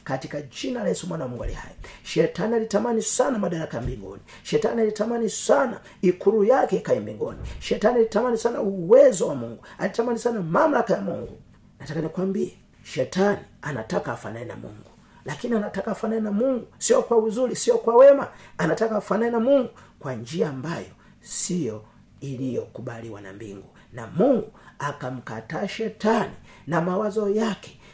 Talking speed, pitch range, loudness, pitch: 145 wpm, 145-225 Hz, -23 LUFS, 200 Hz